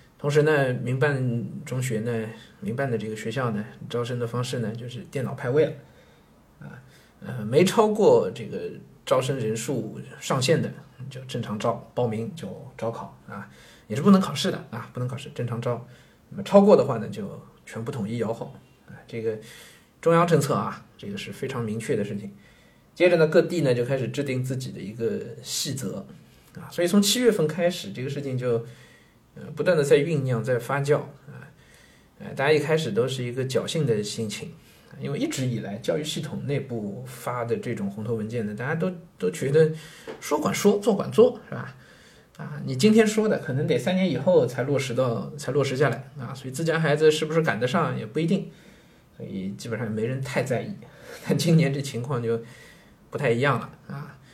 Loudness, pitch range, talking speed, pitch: -25 LUFS, 120-160 Hz, 280 characters per minute, 135 Hz